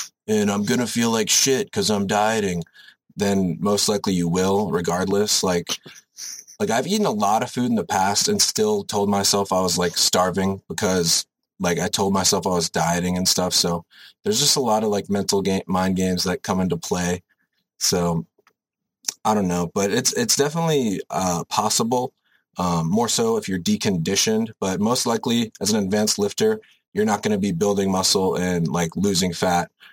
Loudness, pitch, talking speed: -21 LUFS, 100 Hz, 185 wpm